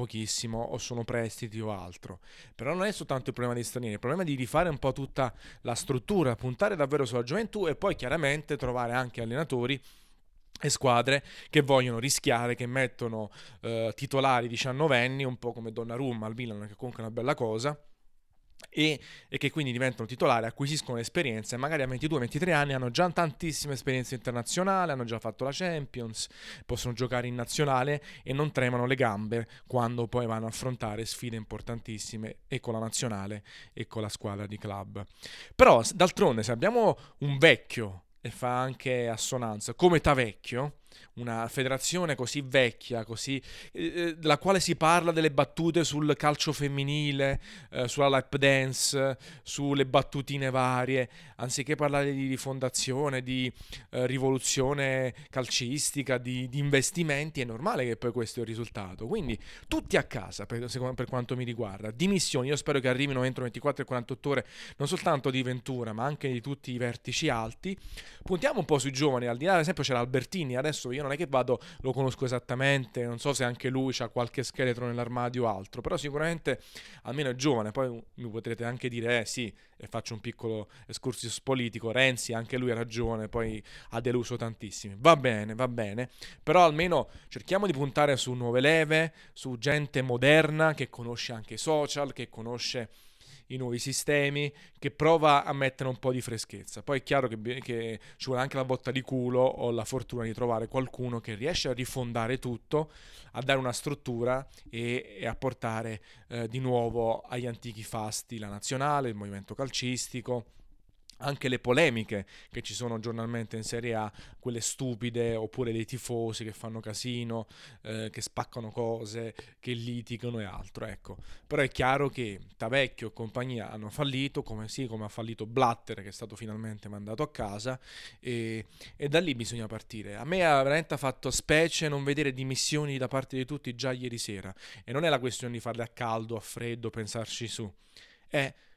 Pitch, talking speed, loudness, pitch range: 125 Hz, 175 wpm, -30 LUFS, 115-140 Hz